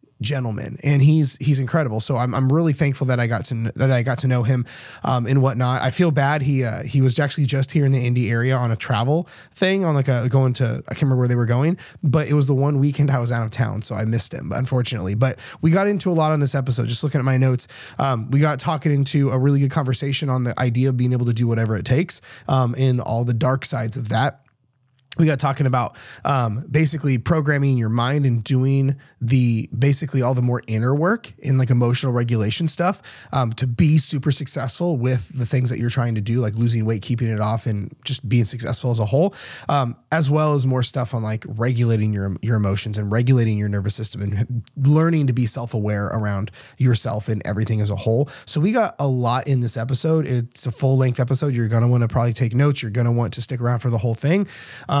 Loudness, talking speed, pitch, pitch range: -20 LUFS, 240 wpm, 130 Hz, 120-140 Hz